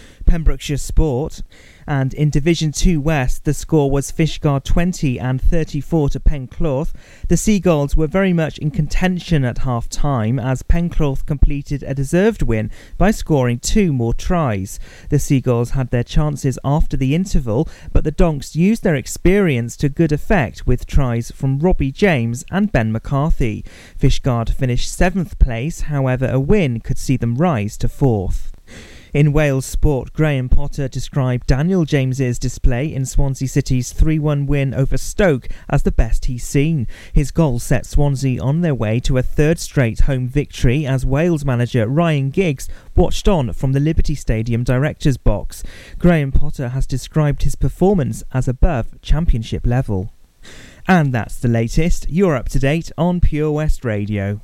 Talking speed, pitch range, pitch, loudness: 160 wpm, 125-155 Hz, 140 Hz, -18 LUFS